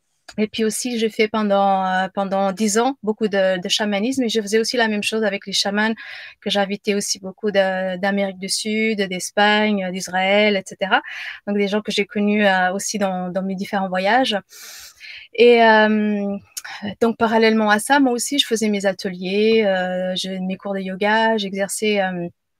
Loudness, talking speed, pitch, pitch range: -19 LUFS, 180 wpm, 205 Hz, 195-220 Hz